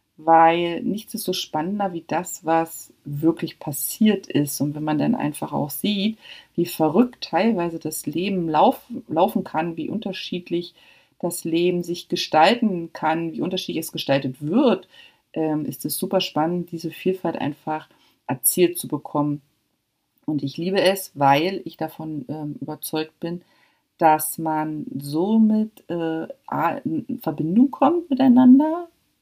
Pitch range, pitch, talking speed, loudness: 155-190 Hz, 165 Hz, 140 wpm, -22 LUFS